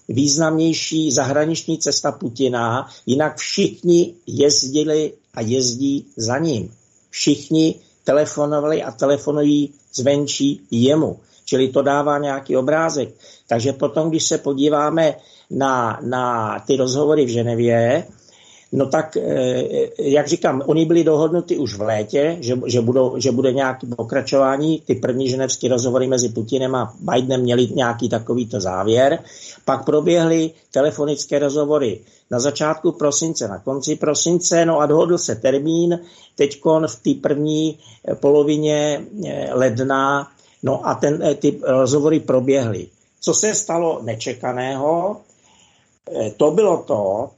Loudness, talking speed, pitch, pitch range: -18 LUFS, 120 wpm, 145 Hz, 130-155 Hz